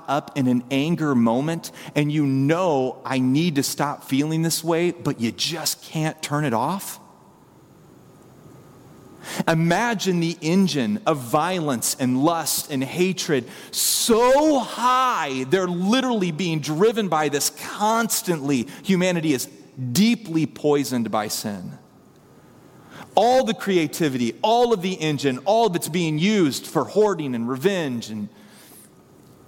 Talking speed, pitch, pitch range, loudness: 130 wpm, 160 Hz, 140-190 Hz, -22 LUFS